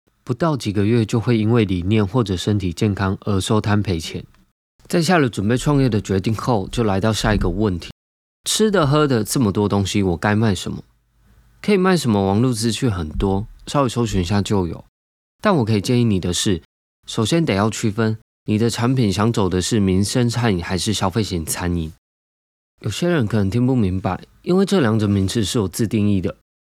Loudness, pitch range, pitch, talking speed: -19 LUFS, 95-120 Hz, 105 Hz, 295 characters per minute